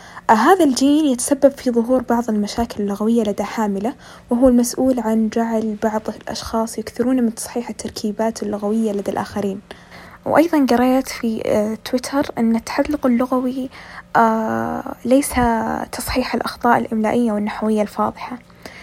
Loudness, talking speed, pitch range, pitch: -19 LUFS, 115 wpm, 215-255 Hz, 230 Hz